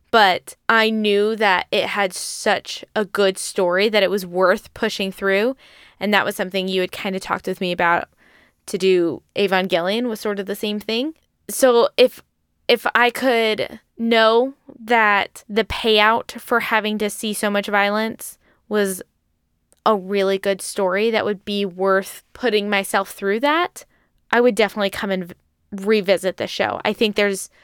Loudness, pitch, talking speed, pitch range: -19 LUFS, 205 Hz, 170 wpm, 195-225 Hz